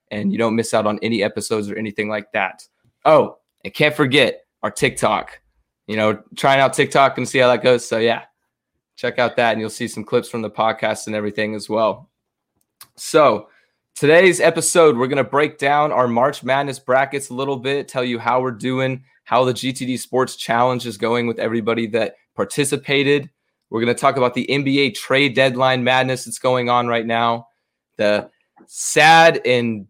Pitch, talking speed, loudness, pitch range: 125 Hz, 190 wpm, -18 LUFS, 115-135 Hz